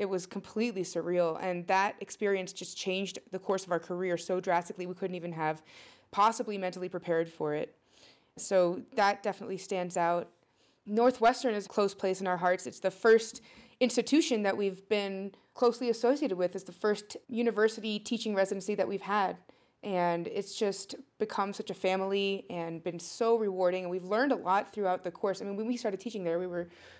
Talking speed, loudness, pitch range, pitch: 190 wpm, -32 LUFS, 180-215 Hz, 195 Hz